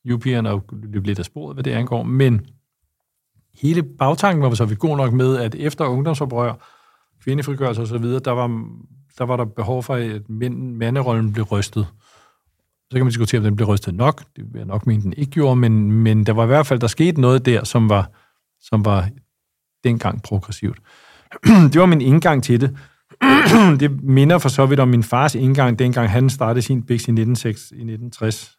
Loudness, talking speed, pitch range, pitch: -17 LUFS, 185 wpm, 110-135 Hz, 125 Hz